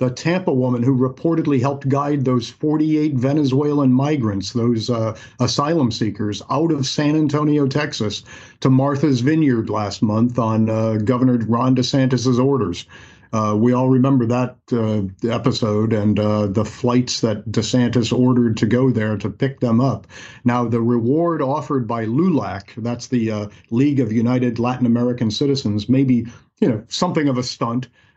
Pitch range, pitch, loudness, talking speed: 115-135 Hz, 125 Hz, -19 LUFS, 160 wpm